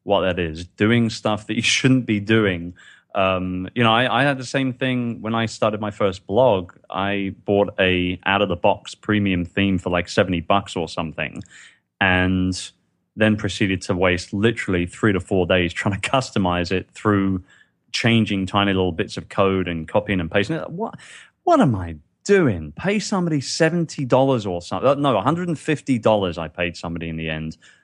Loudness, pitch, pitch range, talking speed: -21 LUFS, 100 Hz, 90-115 Hz, 190 wpm